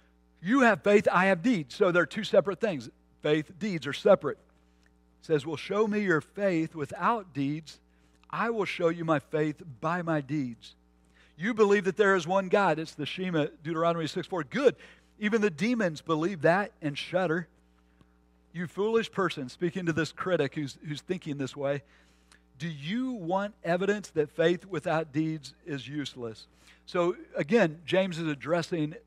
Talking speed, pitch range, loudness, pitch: 165 wpm, 140-190 Hz, -29 LUFS, 165 Hz